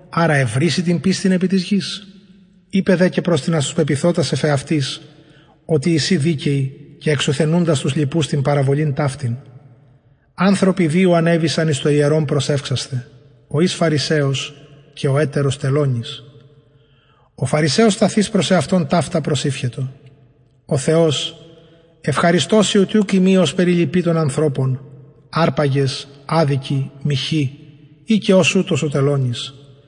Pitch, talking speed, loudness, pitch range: 155 Hz, 120 wpm, -17 LUFS, 140-170 Hz